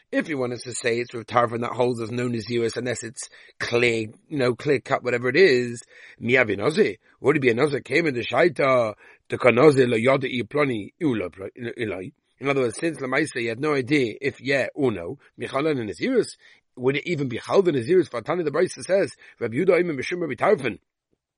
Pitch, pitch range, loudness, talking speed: 125 Hz, 120-140 Hz, -23 LUFS, 200 wpm